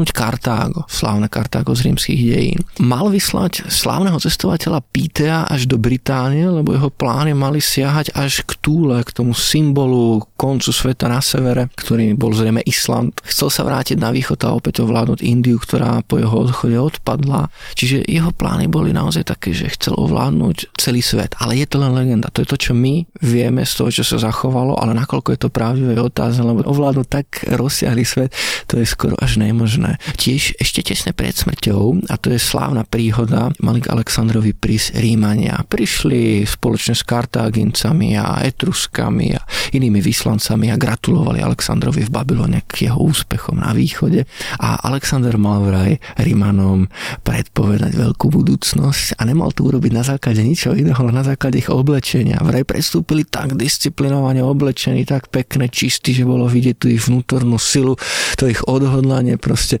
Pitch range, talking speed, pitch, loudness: 115-140 Hz, 160 wpm, 130 Hz, -16 LUFS